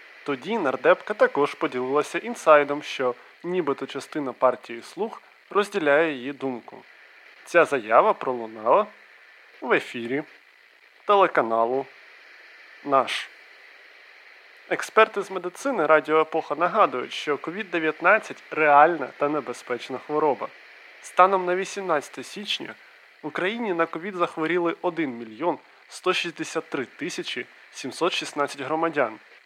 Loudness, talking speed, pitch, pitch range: -24 LUFS, 95 wpm, 155 Hz, 140-180 Hz